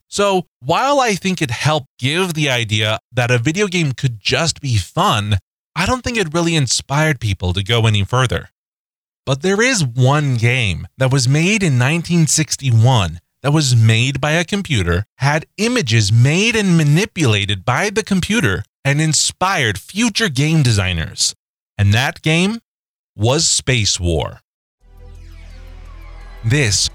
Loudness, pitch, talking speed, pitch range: -16 LUFS, 130 Hz, 140 wpm, 105-165 Hz